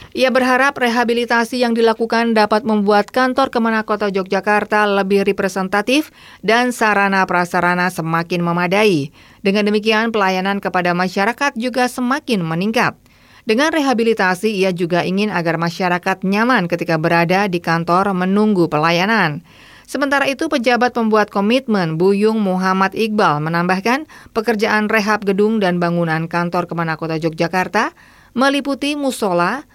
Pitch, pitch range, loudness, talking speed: 205 Hz, 180-235 Hz, -16 LUFS, 120 wpm